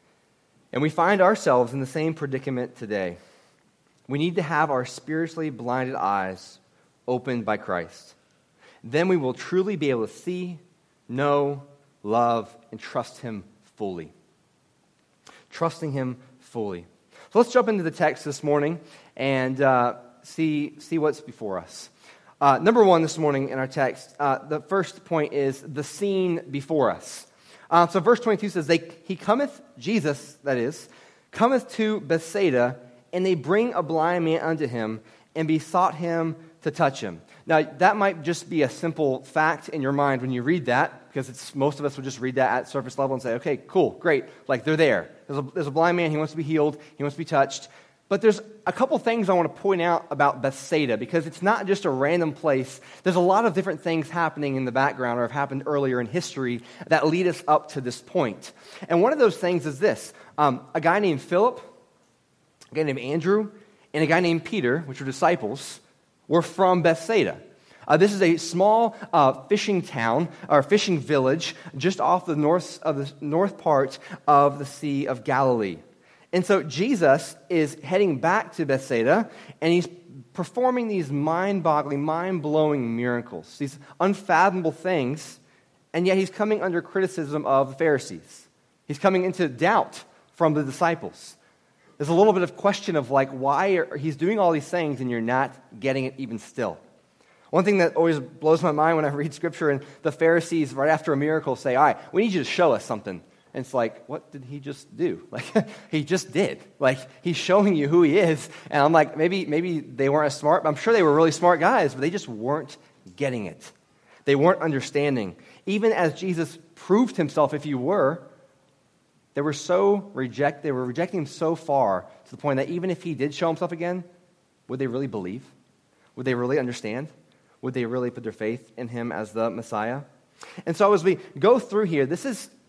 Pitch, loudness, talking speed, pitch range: 155 Hz, -24 LUFS, 195 wpm, 135-180 Hz